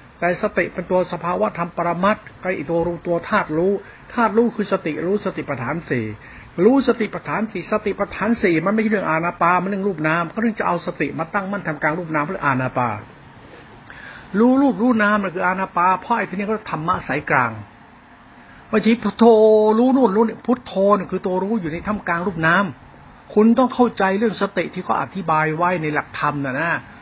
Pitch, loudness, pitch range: 185 Hz, -19 LUFS, 170-215 Hz